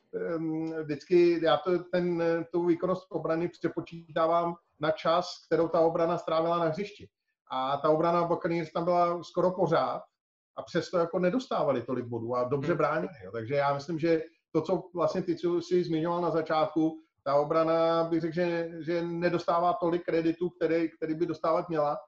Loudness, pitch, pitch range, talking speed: -29 LUFS, 165 Hz, 160-175 Hz, 165 wpm